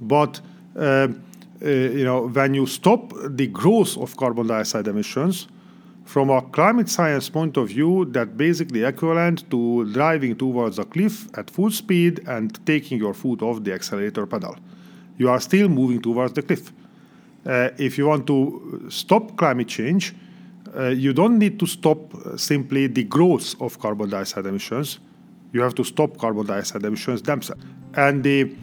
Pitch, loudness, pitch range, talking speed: 140 Hz, -21 LUFS, 120-175 Hz, 165 wpm